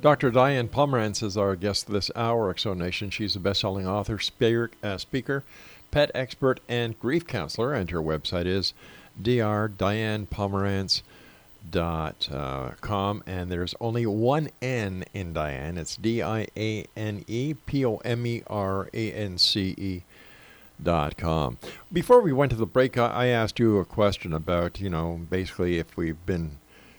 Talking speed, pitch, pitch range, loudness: 145 wpm, 105 Hz, 90-120 Hz, -26 LUFS